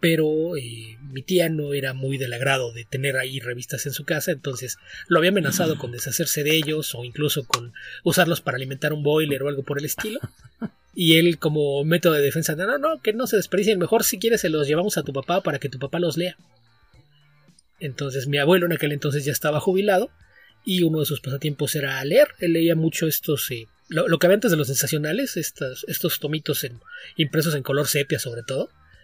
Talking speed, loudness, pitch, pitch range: 215 wpm, -22 LUFS, 150 Hz, 140-170 Hz